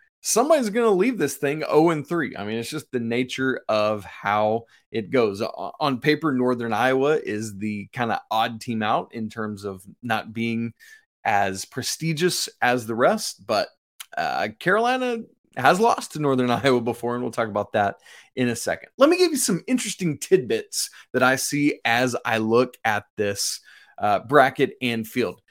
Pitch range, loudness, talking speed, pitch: 115-165 Hz, -23 LUFS, 175 wpm, 125 Hz